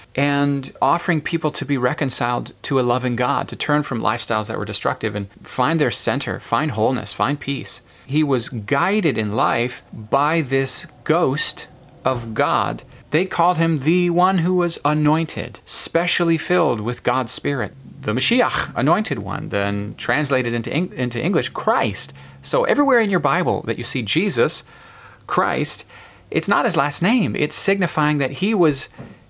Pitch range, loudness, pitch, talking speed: 120-165 Hz, -20 LUFS, 140 Hz, 160 wpm